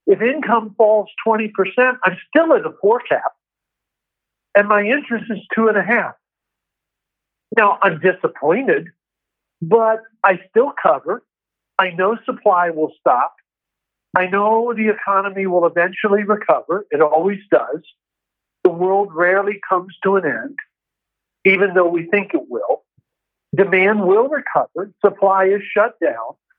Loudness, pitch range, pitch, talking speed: -17 LUFS, 190-230 Hz, 205 Hz, 140 wpm